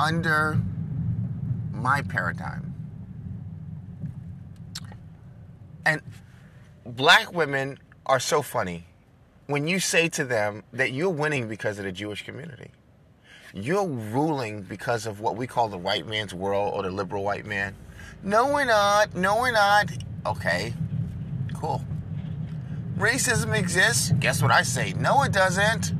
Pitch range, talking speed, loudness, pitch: 105-160 Hz, 125 wpm, -25 LUFS, 140 Hz